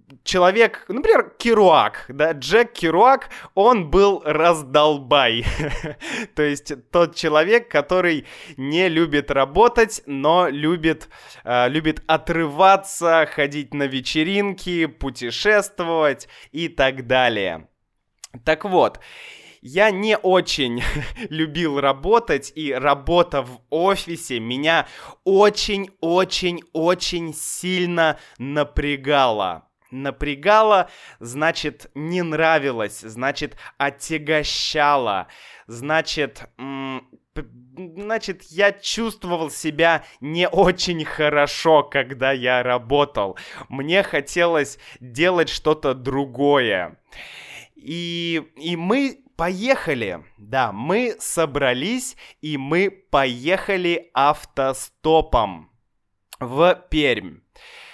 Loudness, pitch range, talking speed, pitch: -20 LUFS, 140-185 Hz, 80 wpm, 160 Hz